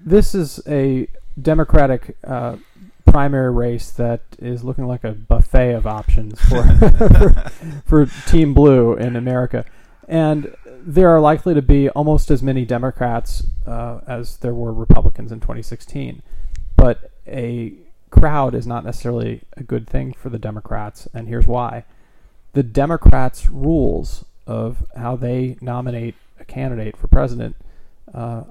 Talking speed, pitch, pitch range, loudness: 135 wpm, 125 Hz, 115-140 Hz, -18 LUFS